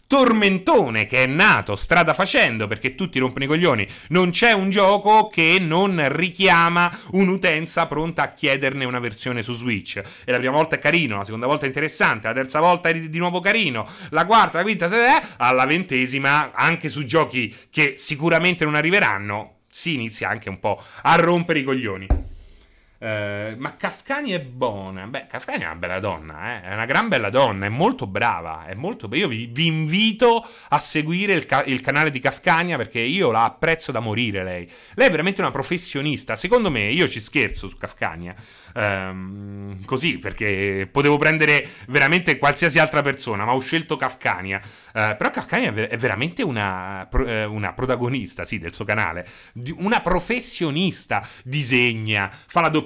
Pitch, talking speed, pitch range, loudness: 135 Hz, 180 wpm, 110-165 Hz, -20 LUFS